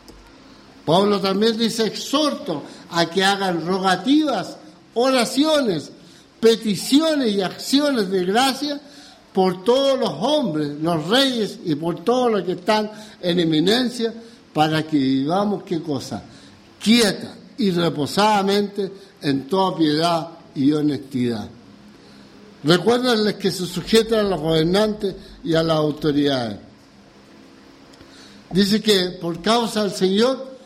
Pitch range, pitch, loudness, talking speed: 160-225 Hz, 195 Hz, -20 LUFS, 115 wpm